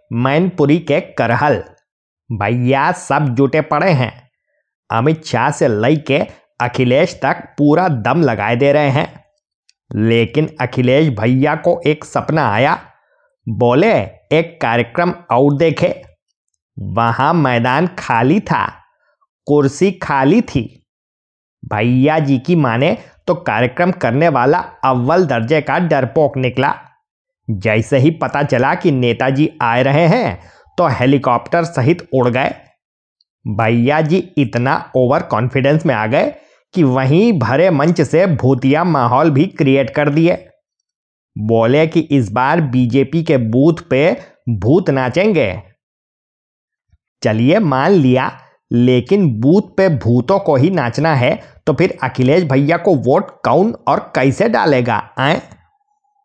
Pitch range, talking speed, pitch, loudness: 125-165 Hz, 125 wpm, 140 Hz, -14 LUFS